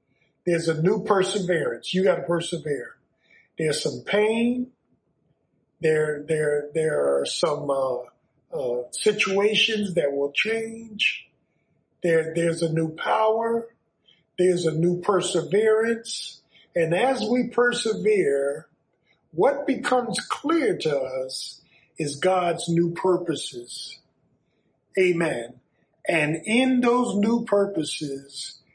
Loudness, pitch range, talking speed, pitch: -24 LUFS, 155-220 Hz, 100 wpm, 175 Hz